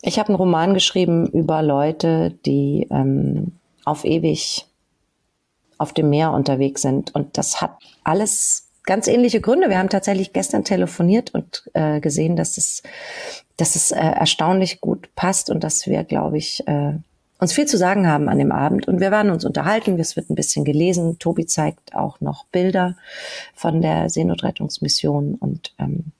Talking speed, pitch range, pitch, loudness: 165 wpm, 155-195 Hz, 170 Hz, -19 LUFS